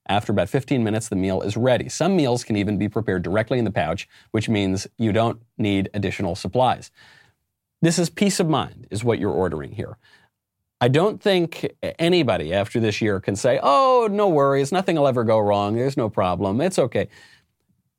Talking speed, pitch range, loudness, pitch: 190 wpm, 100-140 Hz, -21 LUFS, 115 Hz